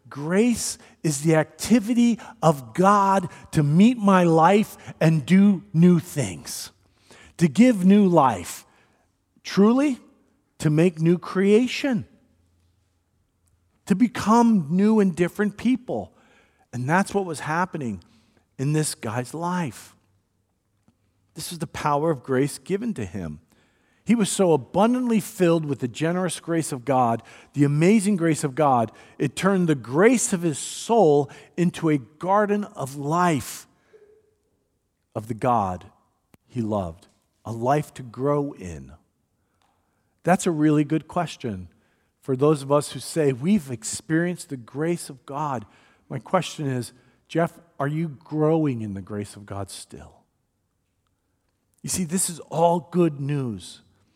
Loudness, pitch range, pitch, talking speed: -22 LUFS, 115-185 Hz, 155 Hz, 135 wpm